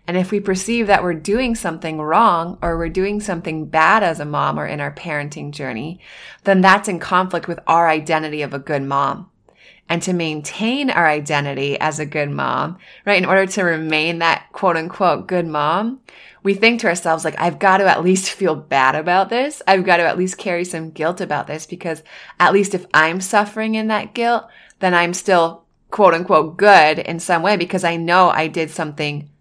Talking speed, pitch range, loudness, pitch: 205 wpm, 155-190 Hz, -17 LUFS, 170 Hz